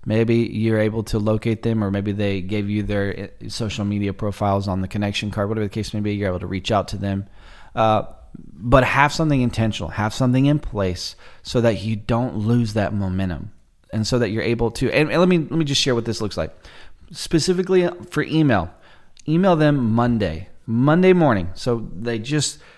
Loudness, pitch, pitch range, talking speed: -21 LUFS, 110 Hz, 100-125 Hz, 200 wpm